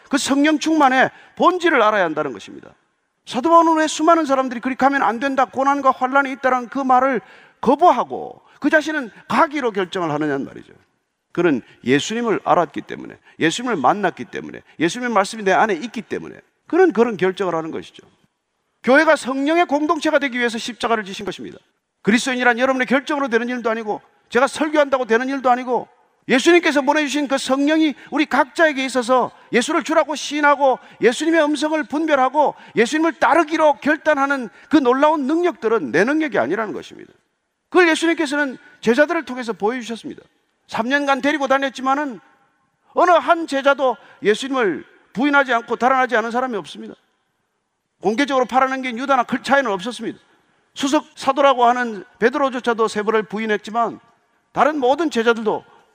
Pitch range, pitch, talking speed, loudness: 235-300 Hz, 270 Hz, 395 characters per minute, -18 LUFS